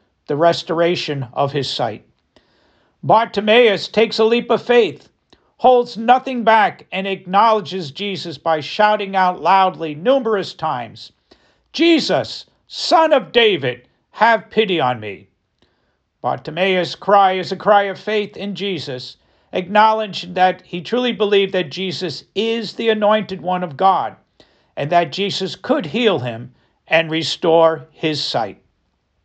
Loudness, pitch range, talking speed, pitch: -17 LUFS, 165-220 Hz, 130 wpm, 190 Hz